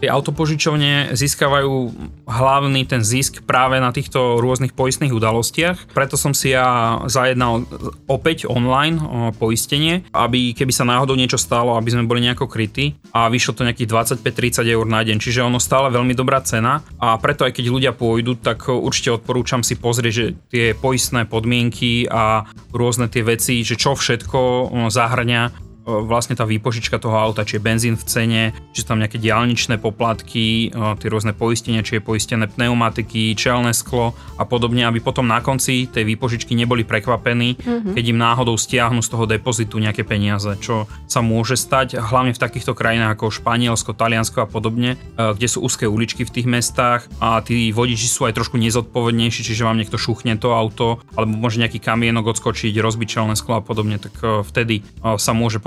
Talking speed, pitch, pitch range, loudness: 170 wpm, 120 Hz, 115-125 Hz, -18 LUFS